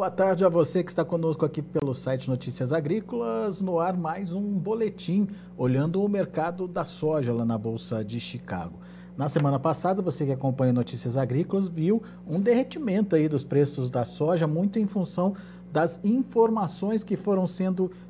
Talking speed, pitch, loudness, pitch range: 170 wpm, 170 Hz, -27 LUFS, 140-195 Hz